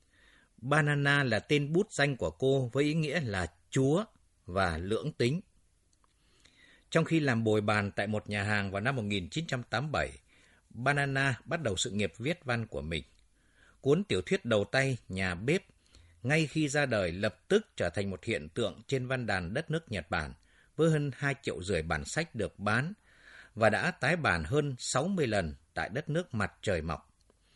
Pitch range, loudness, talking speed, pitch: 100-150 Hz, -31 LUFS, 180 wpm, 125 Hz